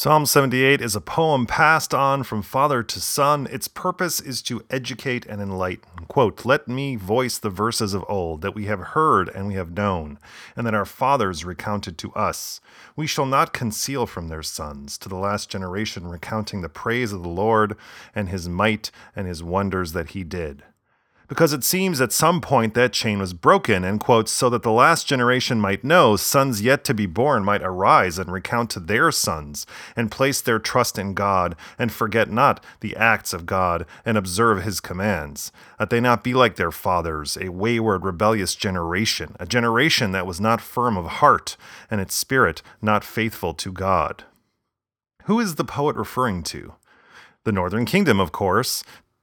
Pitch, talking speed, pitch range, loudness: 105 Hz, 185 wpm, 95-125 Hz, -21 LUFS